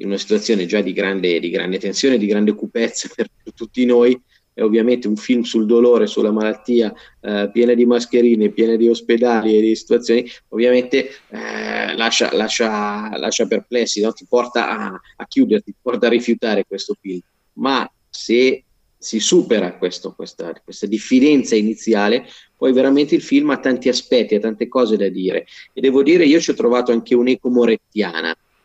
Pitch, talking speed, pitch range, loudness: 115 Hz, 170 wpm, 110-125 Hz, -17 LUFS